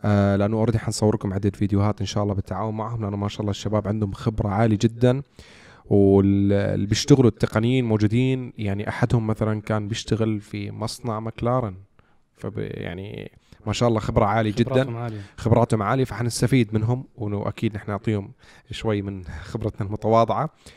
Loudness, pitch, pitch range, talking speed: -23 LUFS, 110 Hz, 100-115 Hz, 145 wpm